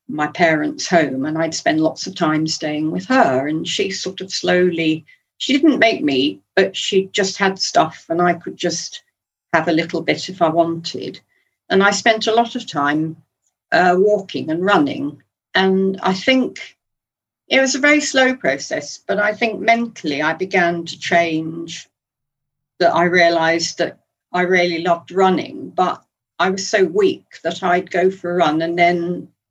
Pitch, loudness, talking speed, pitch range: 175 Hz, -17 LUFS, 175 wpm, 165-210 Hz